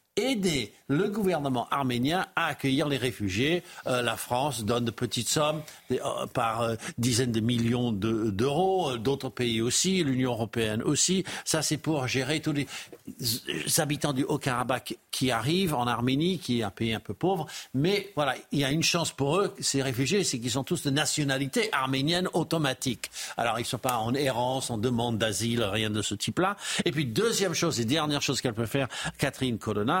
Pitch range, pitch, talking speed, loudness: 120-155 Hz, 135 Hz, 190 wpm, -28 LUFS